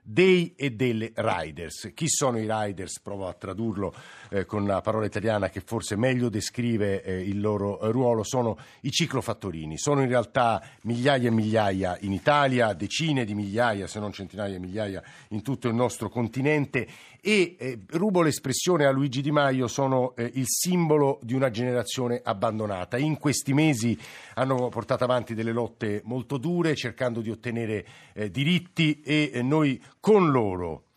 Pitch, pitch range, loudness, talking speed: 120 Hz, 105-140 Hz, -26 LUFS, 165 wpm